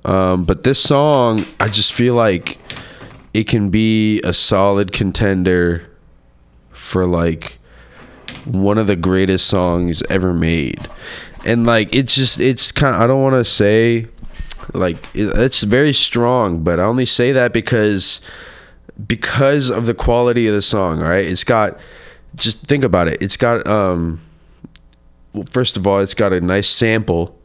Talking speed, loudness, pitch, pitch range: 155 wpm, -15 LUFS, 105 Hz, 90-120 Hz